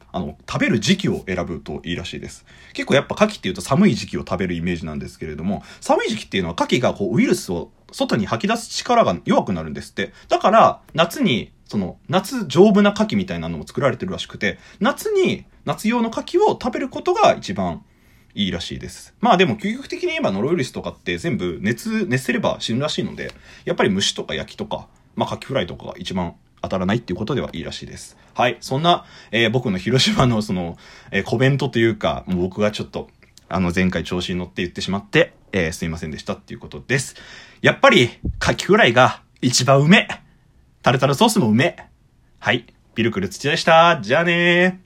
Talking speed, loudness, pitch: 435 characters per minute, -19 LUFS, 165 Hz